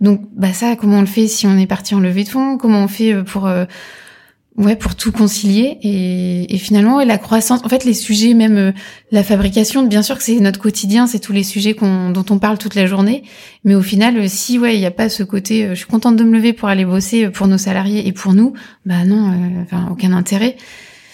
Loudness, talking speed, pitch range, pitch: -14 LUFS, 250 wpm, 195-225 Hz, 210 Hz